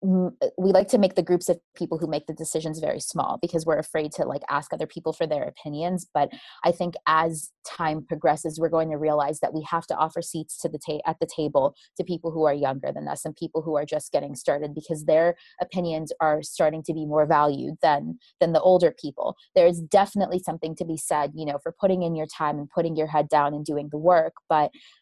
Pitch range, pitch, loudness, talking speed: 150-175 Hz, 160 Hz, -25 LUFS, 235 wpm